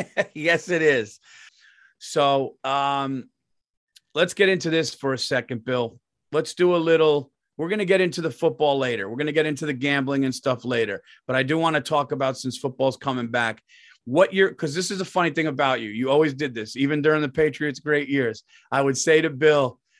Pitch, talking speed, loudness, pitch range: 150 Hz, 205 wpm, -23 LUFS, 130-165 Hz